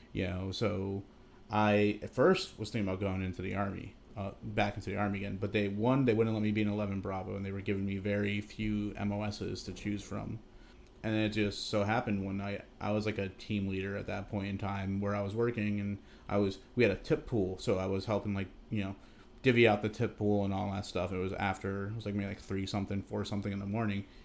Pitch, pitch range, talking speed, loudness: 100 Hz, 100-105 Hz, 250 wpm, -34 LUFS